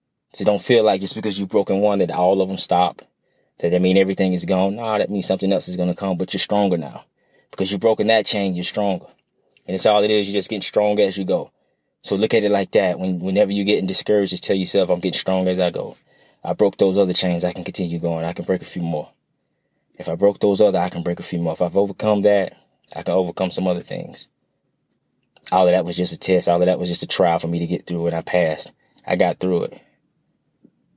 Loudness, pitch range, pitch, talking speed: -19 LUFS, 90-100 Hz, 95 Hz, 260 wpm